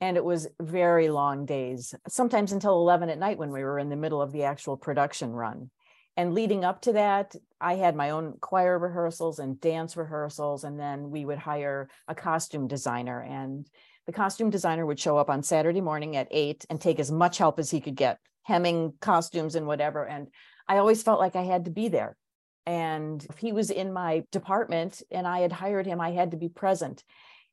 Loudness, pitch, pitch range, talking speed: -28 LUFS, 165 Hz, 145-180 Hz, 210 wpm